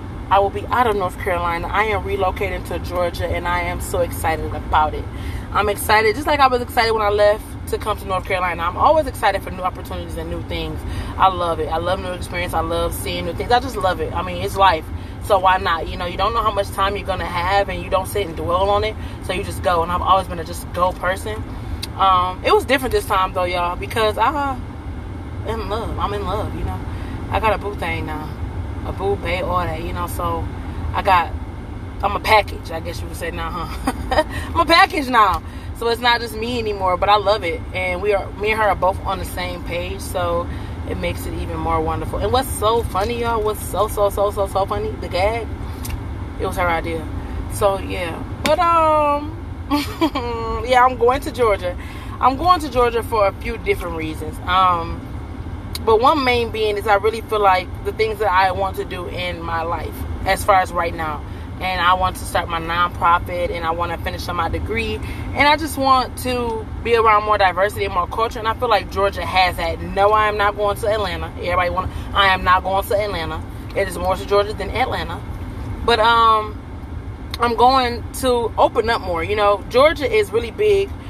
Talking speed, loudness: 225 wpm, -19 LUFS